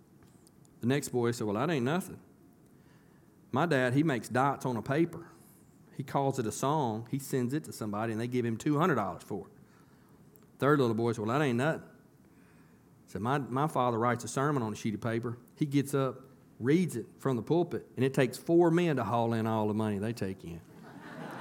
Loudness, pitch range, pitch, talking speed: -31 LUFS, 115-145 Hz, 125 Hz, 215 wpm